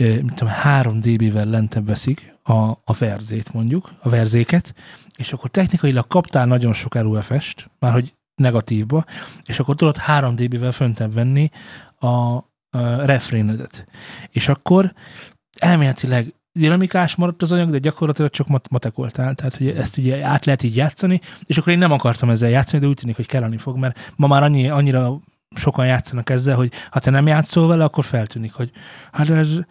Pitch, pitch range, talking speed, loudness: 130 Hz, 120-155 Hz, 160 wpm, -18 LUFS